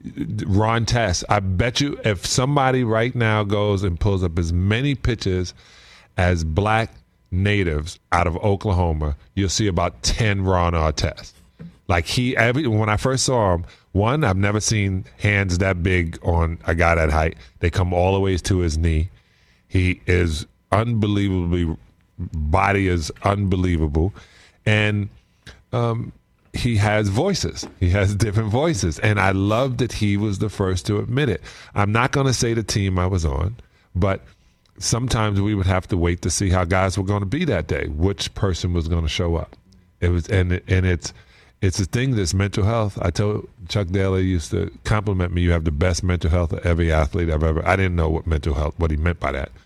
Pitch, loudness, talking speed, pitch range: 95 Hz, -21 LUFS, 190 wpm, 85-105 Hz